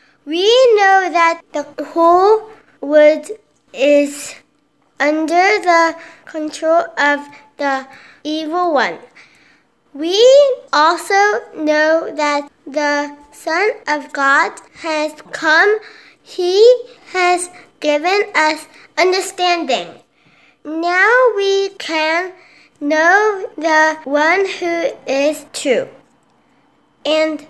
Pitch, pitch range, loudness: 330 Hz, 300-390 Hz, -14 LUFS